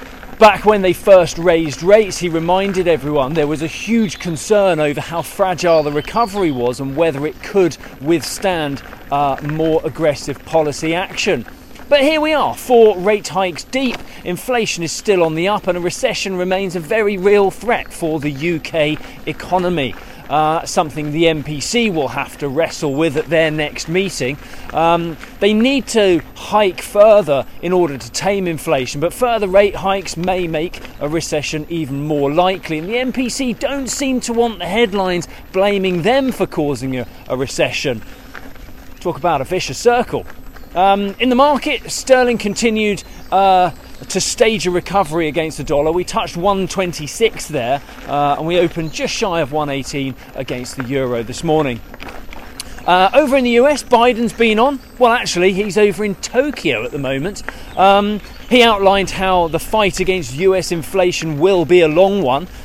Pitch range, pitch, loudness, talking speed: 155-210 Hz, 180 Hz, -16 LUFS, 165 wpm